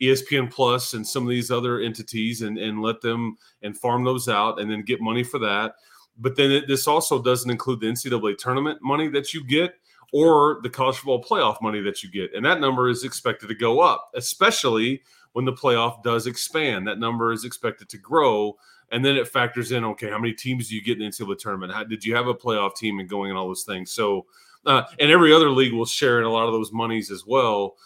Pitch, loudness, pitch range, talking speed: 120 Hz, -22 LUFS, 110-130 Hz, 235 wpm